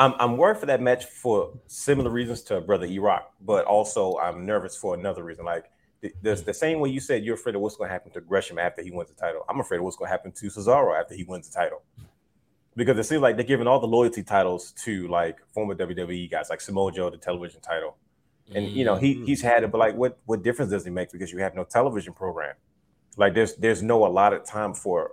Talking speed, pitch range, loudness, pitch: 235 wpm, 95-125 Hz, -25 LUFS, 110 Hz